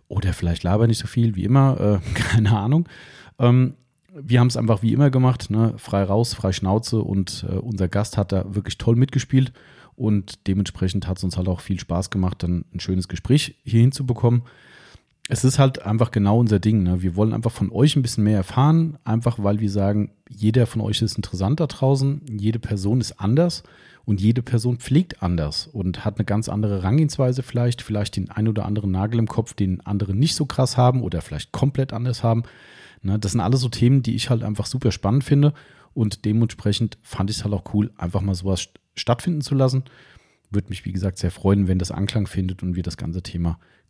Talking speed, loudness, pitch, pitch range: 210 wpm, -21 LUFS, 110 Hz, 100-125 Hz